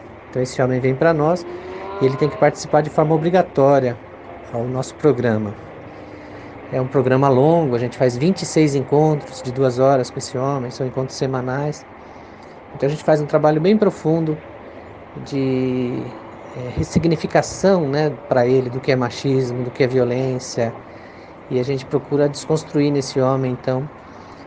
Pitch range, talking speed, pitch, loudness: 125-150 Hz, 160 wpm, 135 Hz, -19 LUFS